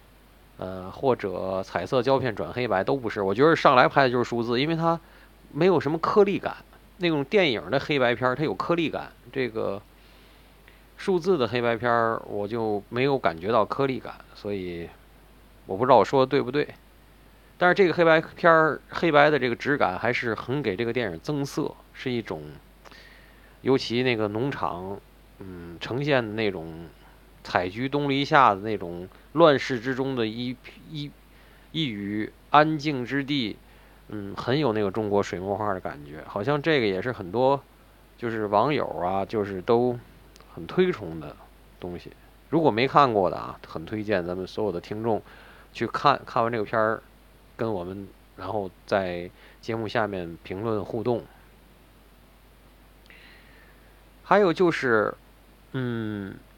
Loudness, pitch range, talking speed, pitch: -25 LUFS, 95-135 Hz, 230 characters per minute, 115 Hz